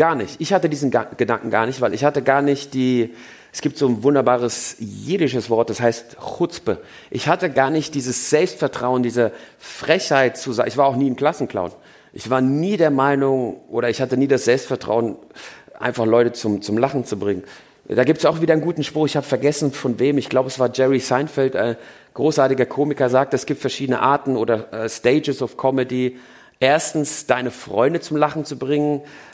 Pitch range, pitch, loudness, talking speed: 120-145 Hz, 135 Hz, -19 LUFS, 200 wpm